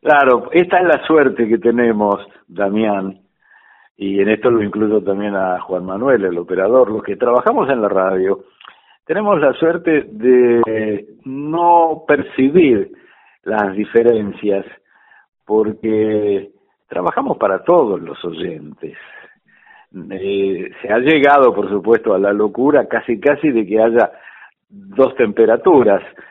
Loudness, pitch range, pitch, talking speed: -15 LUFS, 100-130 Hz, 110 Hz, 125 wpm